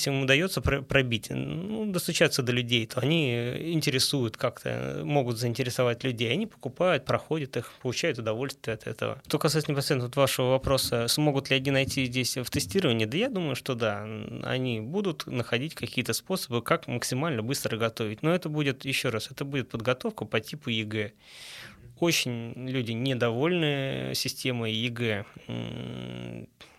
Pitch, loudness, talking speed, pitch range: 130 Hz, -28 LUFS, 150 wpm, 115-145 Hz